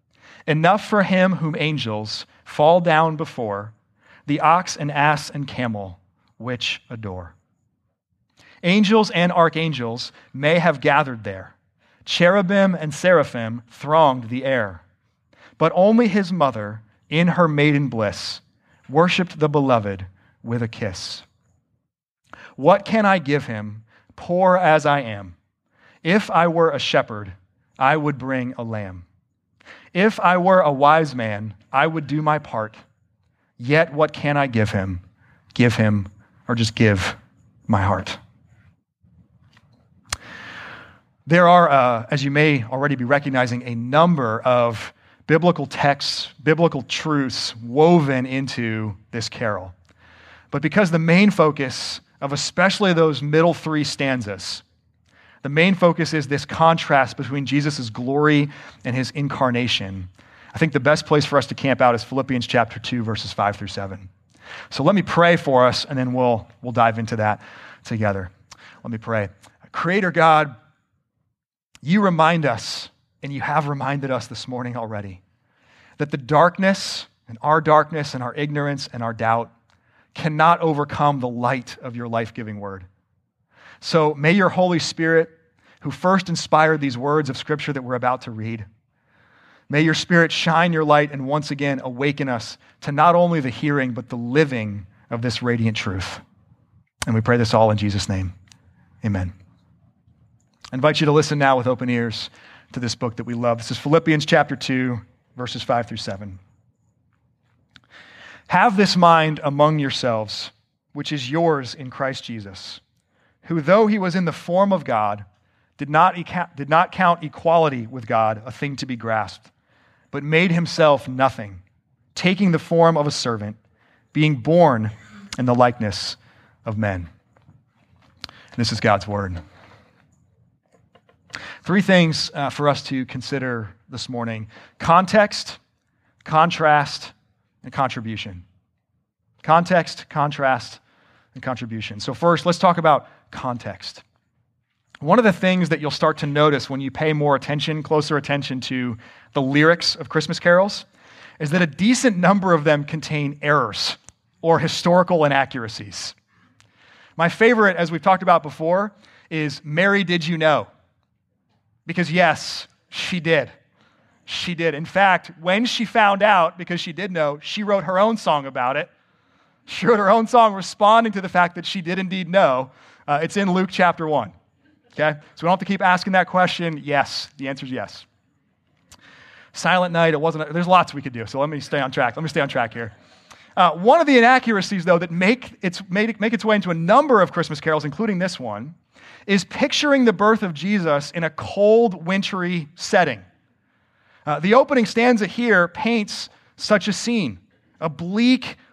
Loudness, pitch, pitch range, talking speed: -19 LUFS, 140 Hz, 115-165 Hz, 155 wpm